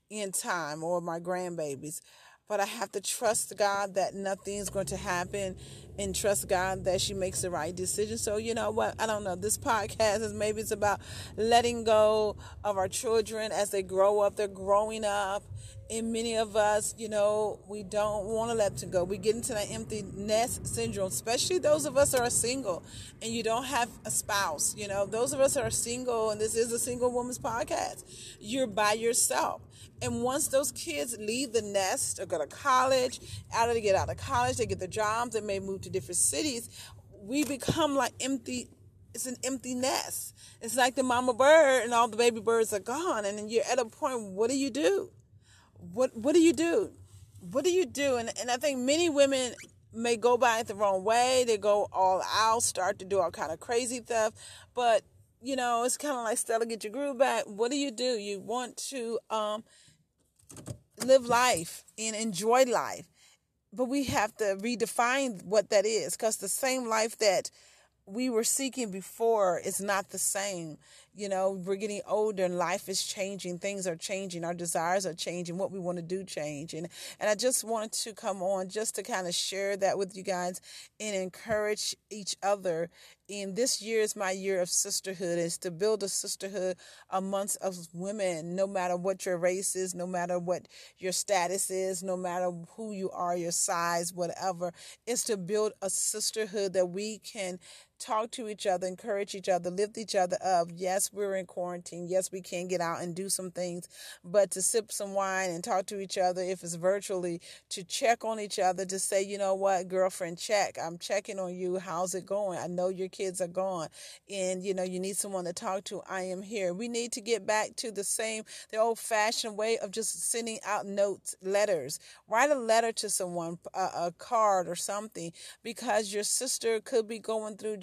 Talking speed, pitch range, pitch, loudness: 205 wpm, 185-230 Hz, 205 Hz, -30 LUFS